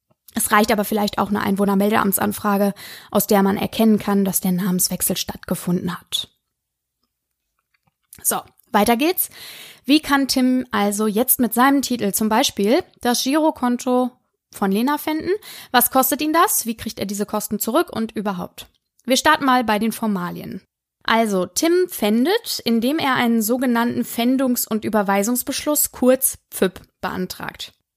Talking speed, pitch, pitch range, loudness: 140 wpm, 230 Hz, 205-260 Hz, -19 LUFS